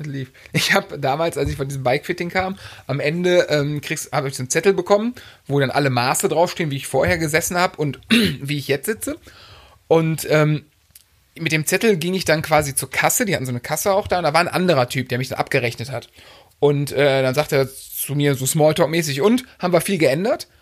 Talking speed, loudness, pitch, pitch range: 225 wpm, -19 LUFS, 150 Hz, 135-175 Hz